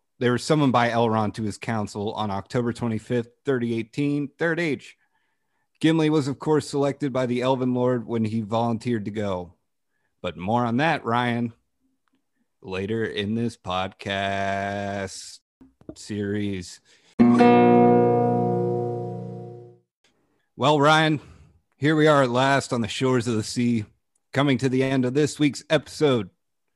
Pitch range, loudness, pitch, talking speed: 100-135 Hz, -23 LUFS, 120 Hz, 130 wpm